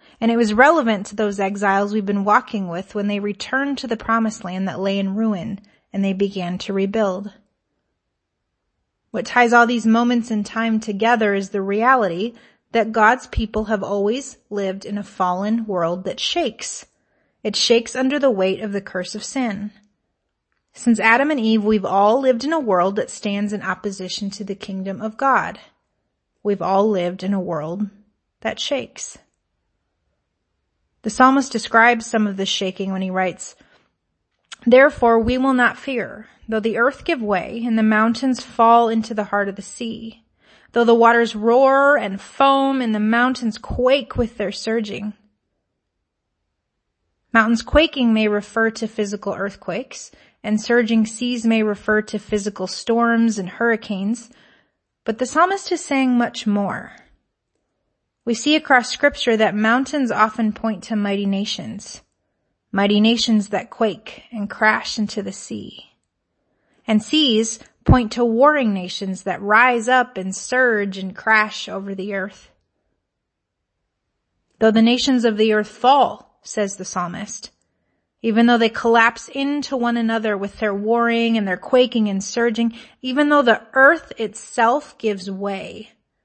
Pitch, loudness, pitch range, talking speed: 215 Hz, -19 LUFS, 200-235 Hz, 155 wpm